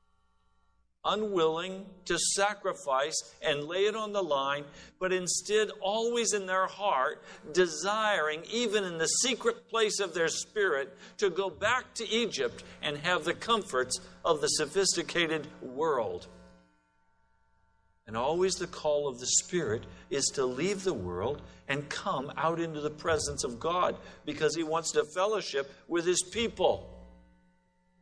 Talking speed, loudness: 140 wpm, -30 LUFS